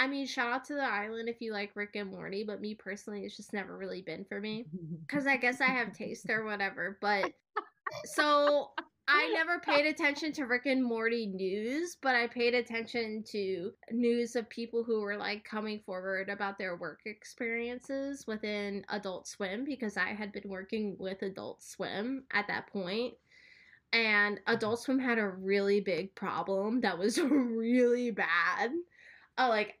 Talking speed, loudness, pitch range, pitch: 175 wpm, -33 LUFS, 205-255 Hz, 225 Hz